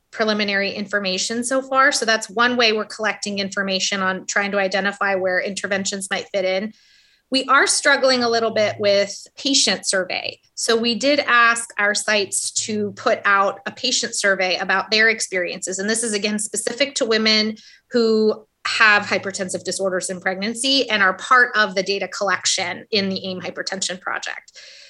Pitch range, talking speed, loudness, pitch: 195-230 Hz, 165 wpm, -19 LUFS, 205 Hz